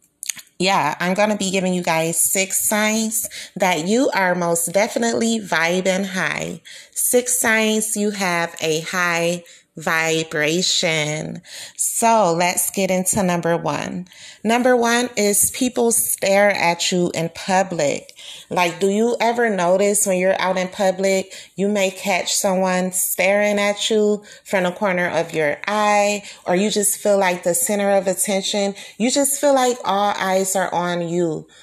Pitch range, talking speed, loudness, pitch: 175-210 Hz, 150 wpm, -18 LUFS, 190 Hz